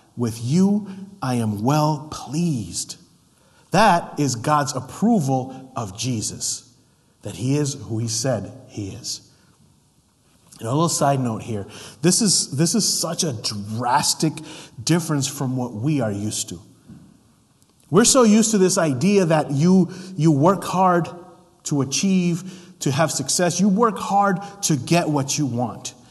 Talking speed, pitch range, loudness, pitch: 145 wpm, 125-180 Hz, -20 LUFS, 150 Hz